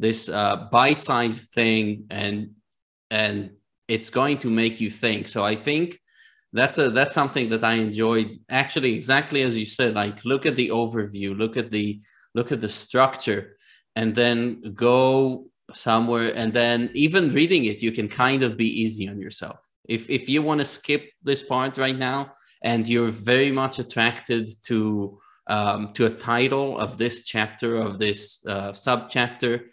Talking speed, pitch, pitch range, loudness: 170 wpm, 115 Hz, 105-130 Hz, -23 LUFS